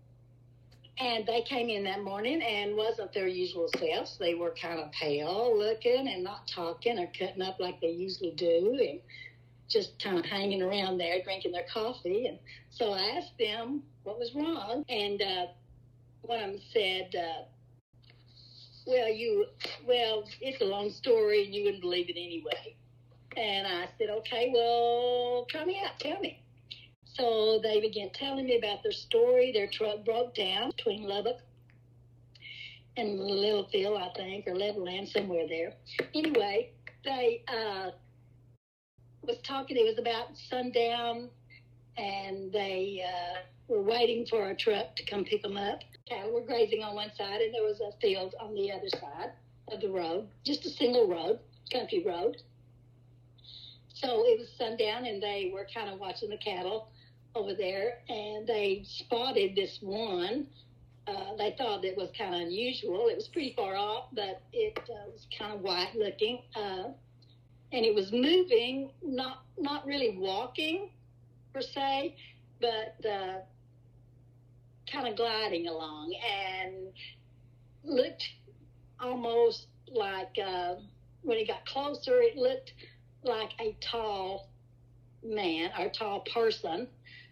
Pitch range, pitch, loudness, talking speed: 160-245 Hz, 205 Hz, -32 LUFS, 150 wpm